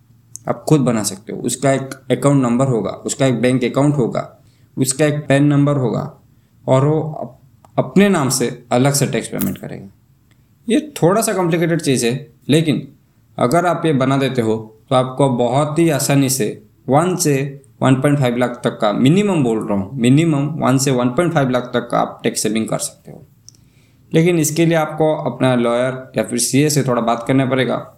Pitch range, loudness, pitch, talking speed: 120-145 Hz, -16 LUFS, 130 Hz, 185 wpm